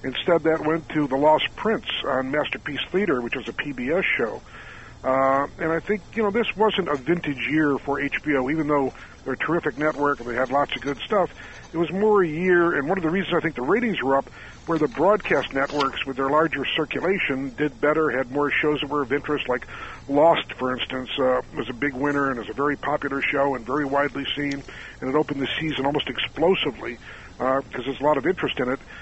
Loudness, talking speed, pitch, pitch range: -23 LUFS, 225 wpm, 145 Hz, 135-155 Hz